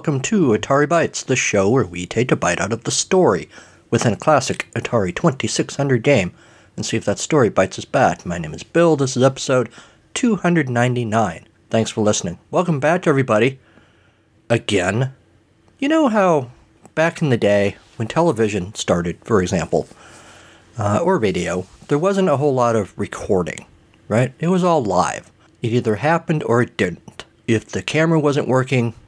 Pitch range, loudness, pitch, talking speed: 110-155 Hz, -19 LUFS, 125 Hz, 170 wpm